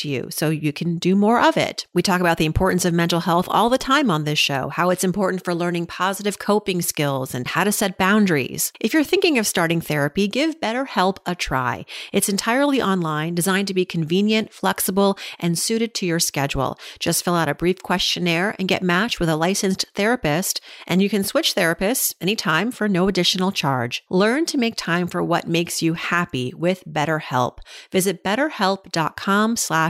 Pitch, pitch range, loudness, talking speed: 185 Hz, 170-205 Hz, -20 LUFS, 190 wpm